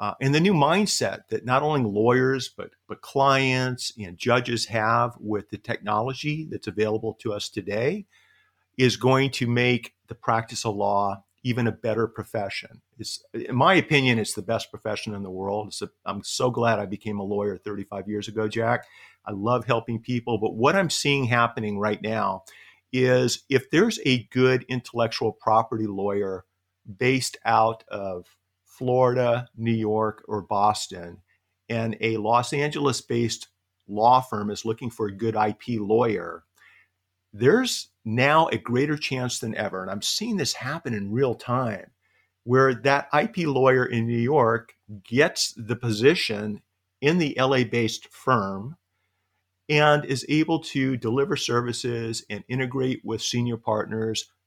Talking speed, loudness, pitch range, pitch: 155 wpm, -24 LUFS, 105-130 Hz, 115 Hz